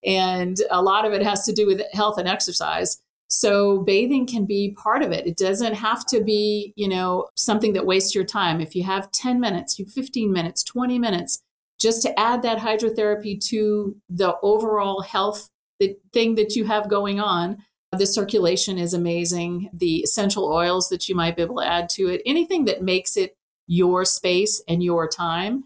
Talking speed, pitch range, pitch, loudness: 190 wpm, 185-215 Hz, 200 Hz, -20 LUFS